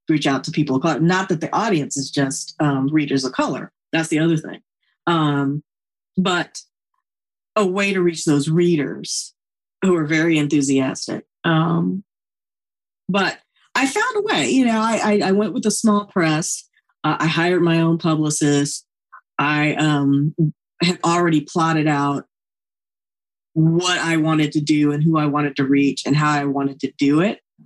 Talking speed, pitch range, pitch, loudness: 170 wpm, 145-175 Hz, 160 Hz, -19 LUFS